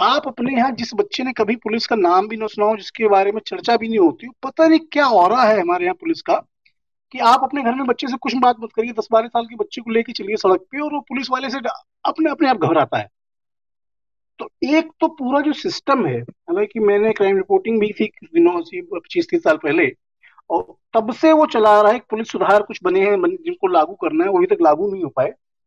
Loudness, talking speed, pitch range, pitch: -18 LUFS, 245 wpm, 220-325 Hz, 260 Hz